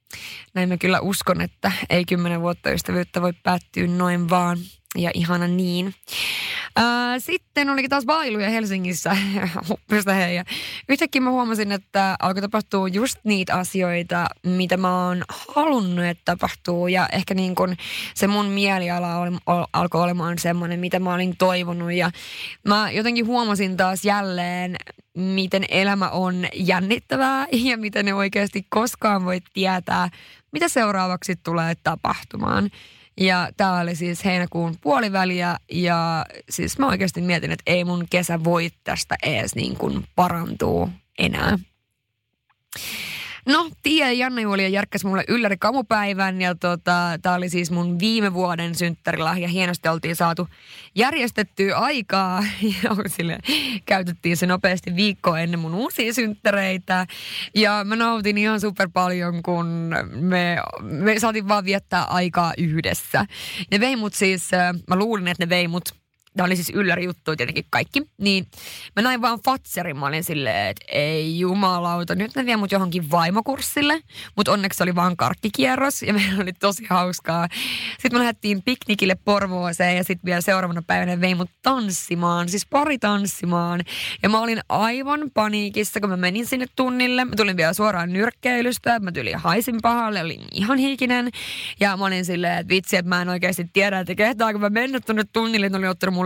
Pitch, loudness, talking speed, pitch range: 185 Hz, -21 LUFS, 150 wpm, 175-215 Hz